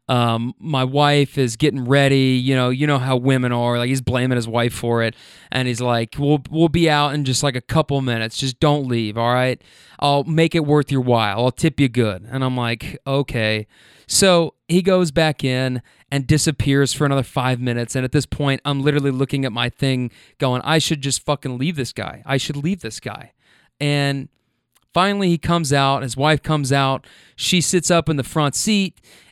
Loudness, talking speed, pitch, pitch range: -19 LUFS, 210 wpm, 135 Hz, 125-150 Hz